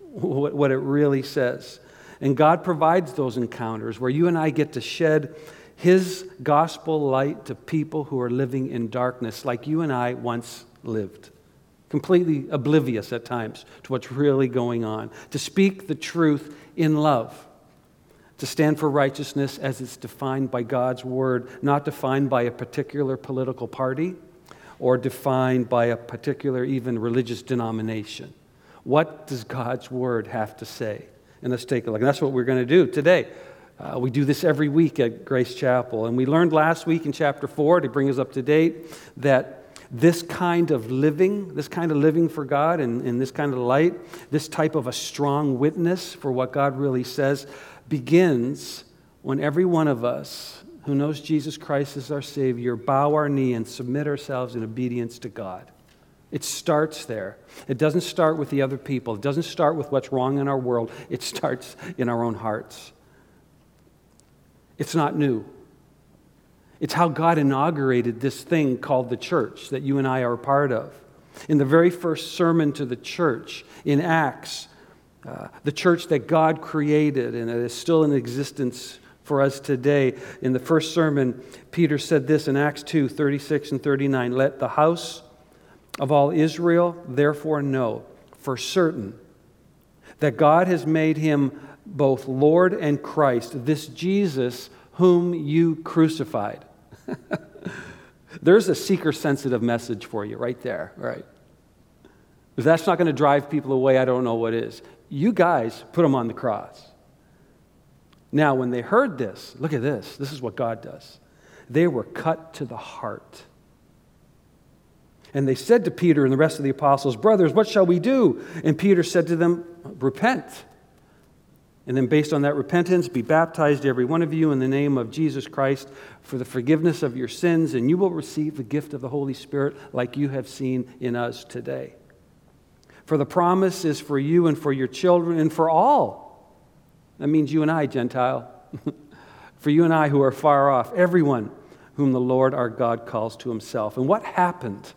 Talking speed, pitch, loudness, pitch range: 175 wpm, 140 Hz, -23 LUFS, 125-155 Hz